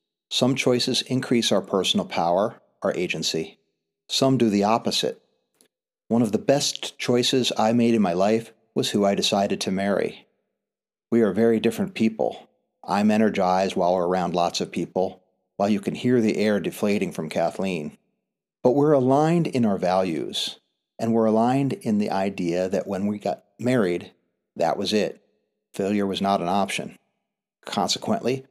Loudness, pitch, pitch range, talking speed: -23 LUFS, 110 Hz, 100-125 Hz, 160 wpm